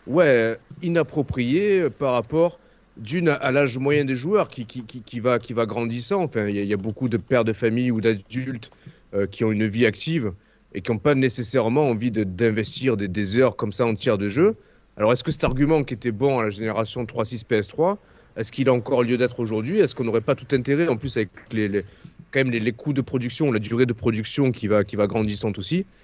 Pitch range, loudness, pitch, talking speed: 110-135 Hz, -23 LUFS, 120 Hz, 235 wpm